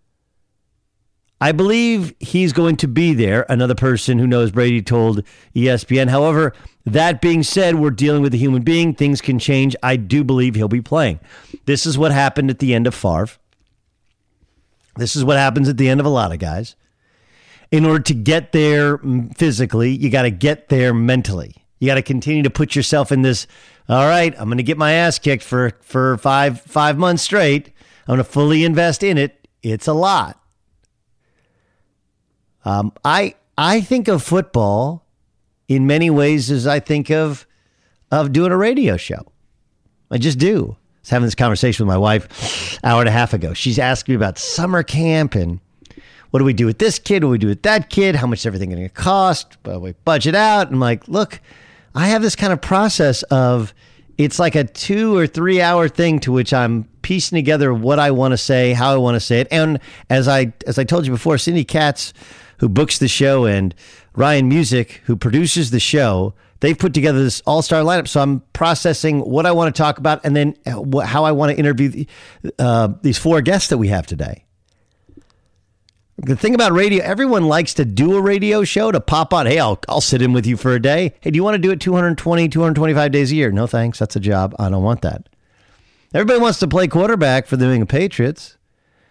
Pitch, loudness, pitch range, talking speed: 135 Hz, -16 LUFS, 115-160 Hz, 205 wpm